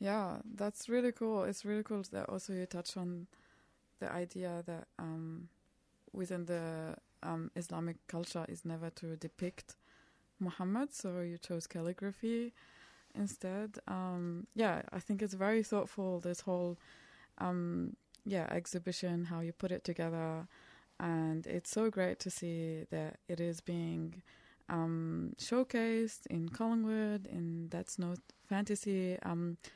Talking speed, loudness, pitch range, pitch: 135 wpm, -40 LUFS, 170-205 Hz, 180 Hz